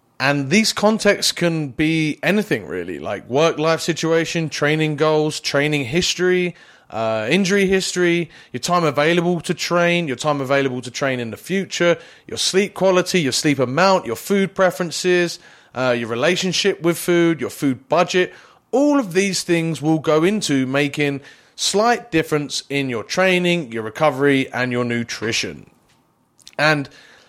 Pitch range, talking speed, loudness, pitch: 140-180 Hz, 145 wpm, -19 LUFS, 165 Hz